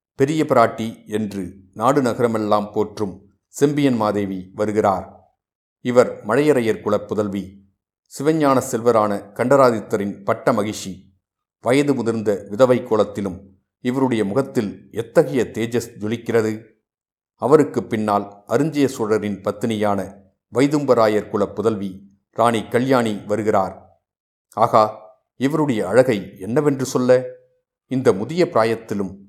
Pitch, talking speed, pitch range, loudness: 110 Hz, 95 wpm, 100-125 Hz, -20 LUFS